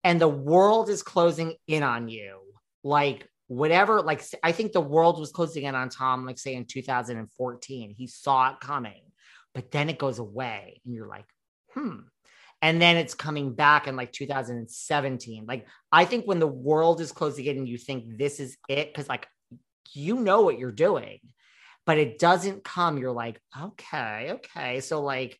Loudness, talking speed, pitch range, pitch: -25 LUFS, 180 wpm, 130-165 Hz, 145 Hz